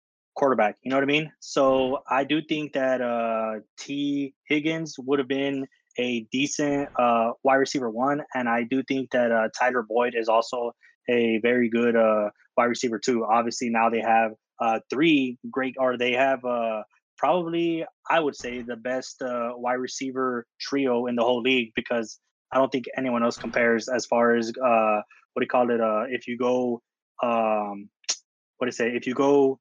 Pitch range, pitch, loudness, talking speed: 115-135 Hz, 125 Hz, -25 LUFS, 185 wpm